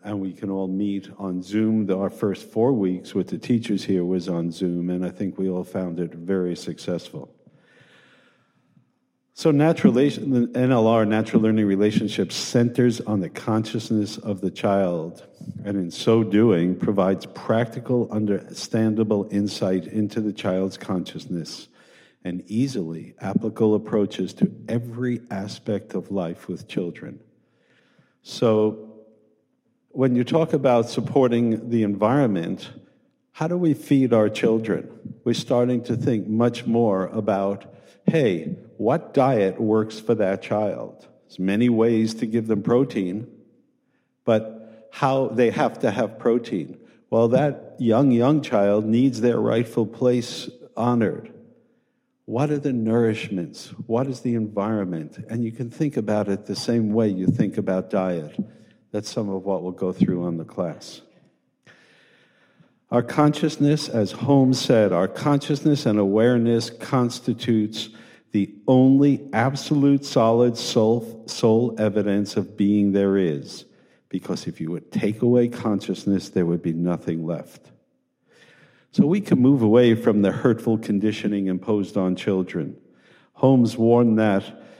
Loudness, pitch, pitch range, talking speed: -22 LUFS, 110 Hz, 100-120 Hz, 140 wpm